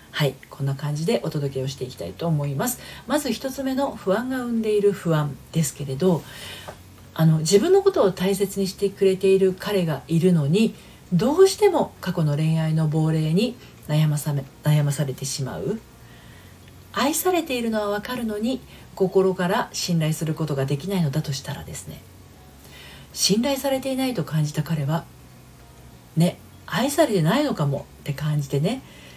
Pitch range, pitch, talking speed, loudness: 145-210 Hz, 165 Hz, 330 characters per minute, -23 LUFS